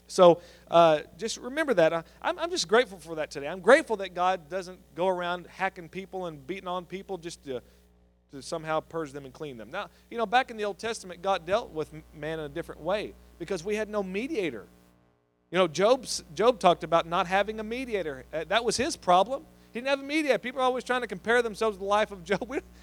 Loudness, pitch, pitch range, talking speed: -28 LUFS, 185 Hz, 160-220 Hz, 230 wpm